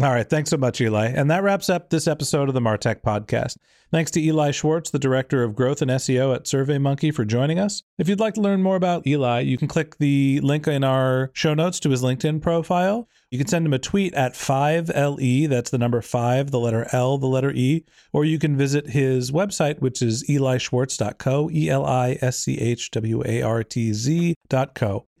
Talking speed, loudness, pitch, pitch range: 215 wpm, -22 LUFS, 140 Hz, 125-155 Hz